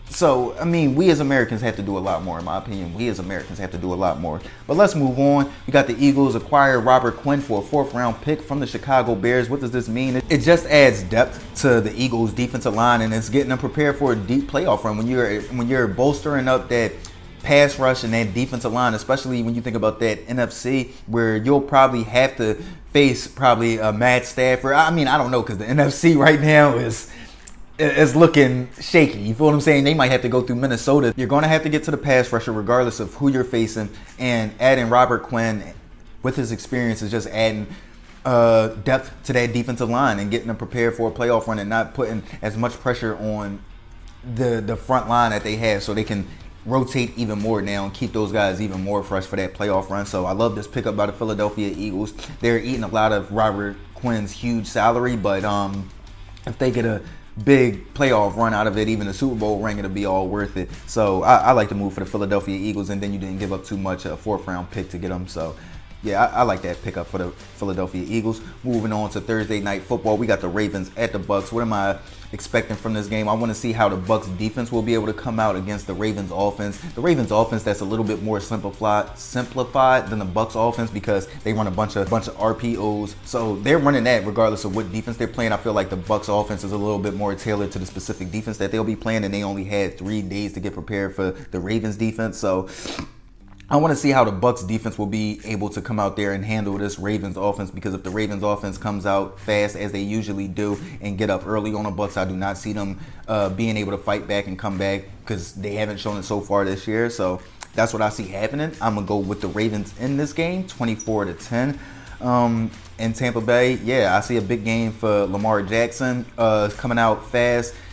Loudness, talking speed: -21 LUFS, 240 wpm